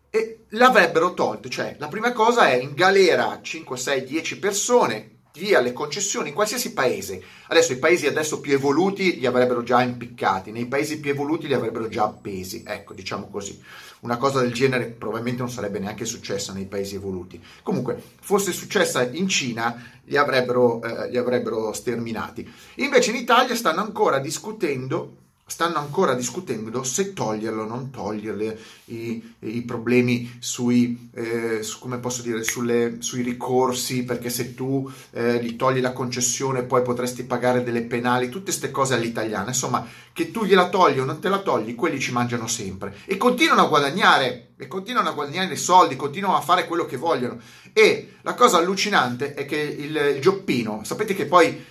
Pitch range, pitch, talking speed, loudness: 120-165 Hz, 125 Hz, 175 wpm, -22 LUFS